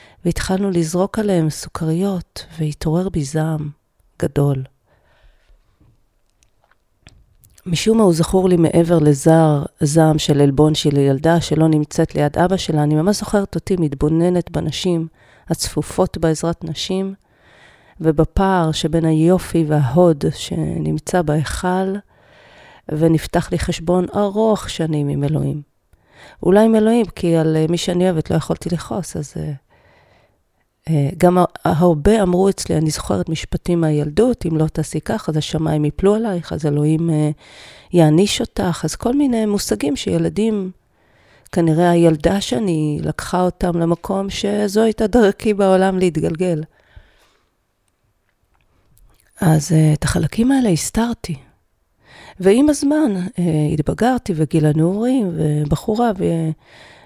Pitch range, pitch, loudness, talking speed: 155-190 Hz, 165 Hz, -17 LUFS, 120 wpm